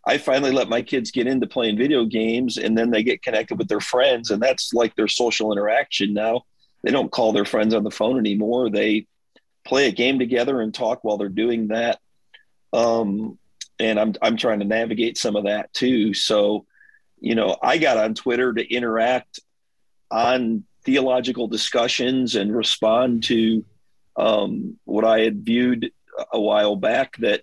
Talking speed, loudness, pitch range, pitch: 175 wpm, -21 LUFS, 105-120 Hz, 115 Hz